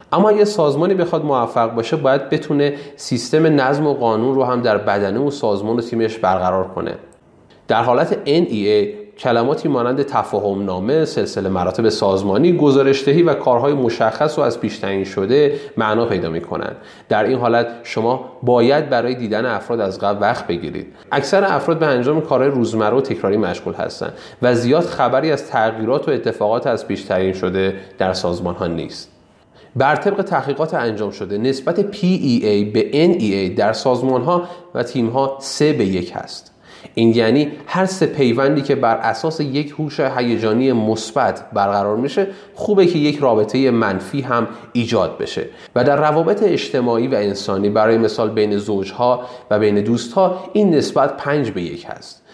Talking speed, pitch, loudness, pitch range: 160 wpm, 125 Hz, -17 LUFS, 110-150 Hz